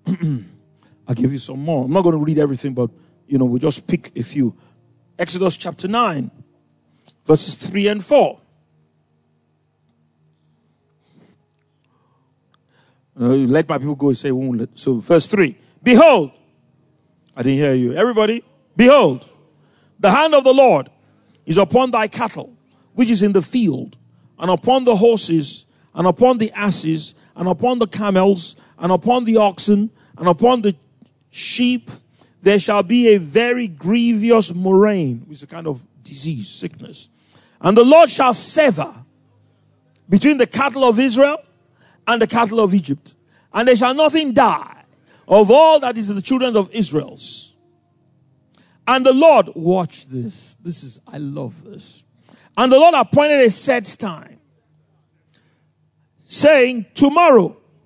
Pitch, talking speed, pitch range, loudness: 175 Hz, 145 wpm, 140-230 Hz, -15 LUFS